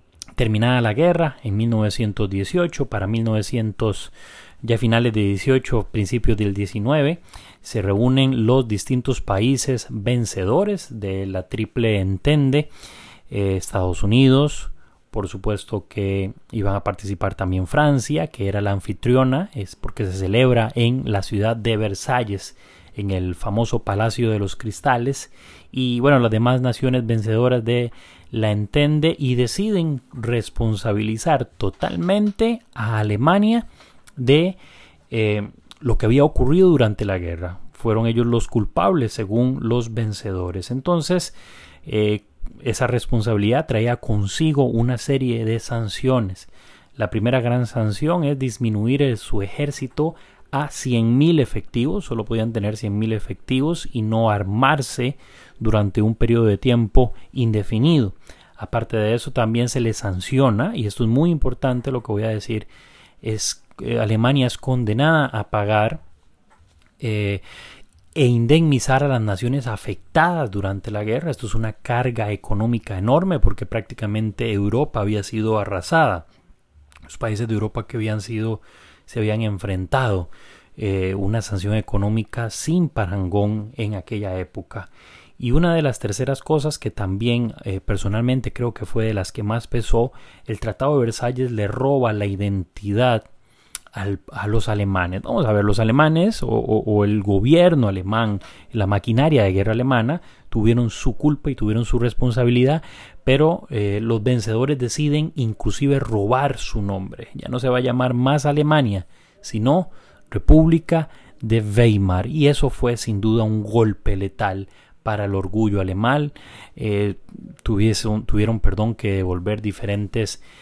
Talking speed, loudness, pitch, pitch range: 140 wpm, -21 LUFS, 115 Hz, 105-130 Hz